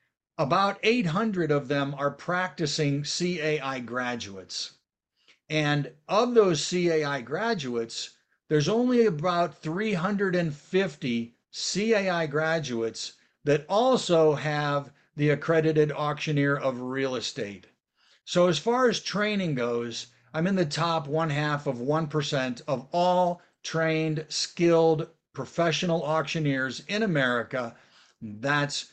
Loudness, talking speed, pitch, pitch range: -27 LUFS, 105 wpm, 155 Hz, 140-180 Hz